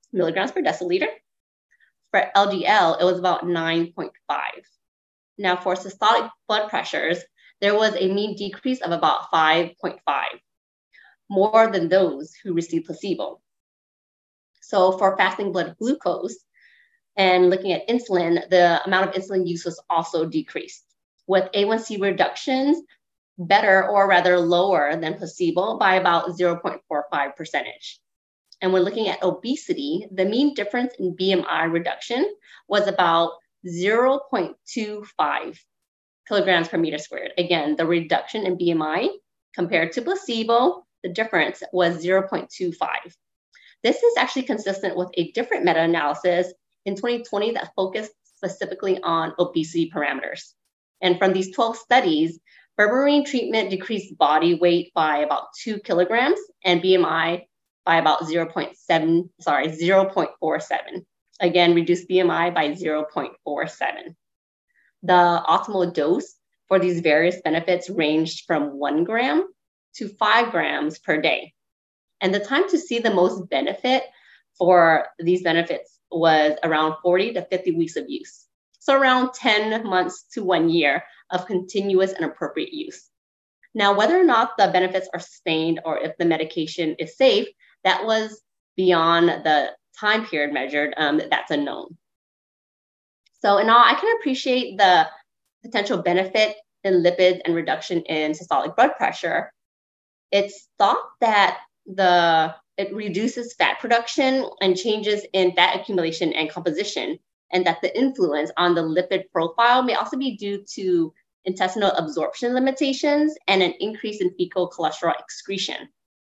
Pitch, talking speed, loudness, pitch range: 185 Hz, 130 wpm, -21 LUFS, 170-215 Hz